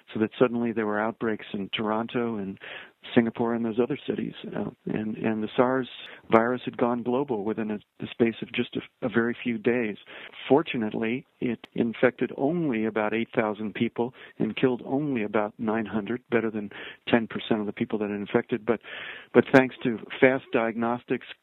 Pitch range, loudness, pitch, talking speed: 110-125 Hz, -27 LUFS, 115 Hz, 170 wpm